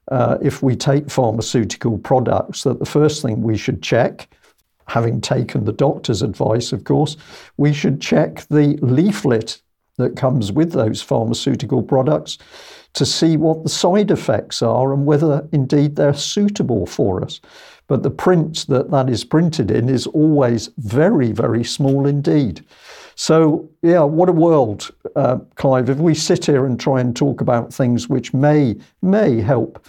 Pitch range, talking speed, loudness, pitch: 125-155 Hz, 160 wpm, -17 LUFS, 140 Hz